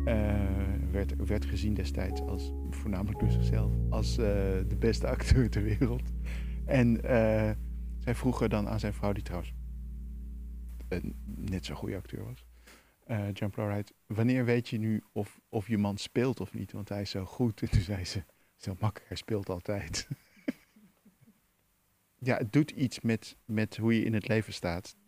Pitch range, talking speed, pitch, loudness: 70-110 Hz, 170 wpm, 100 Hz, -32 LUFS